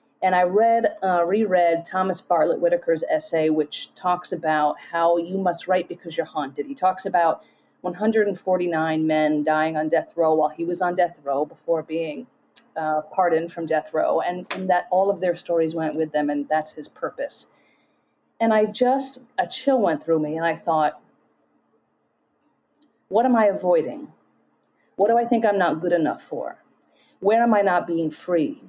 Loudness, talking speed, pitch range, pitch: -22 LUFS, 180 wpm, 155-200 Hz, 175 Hz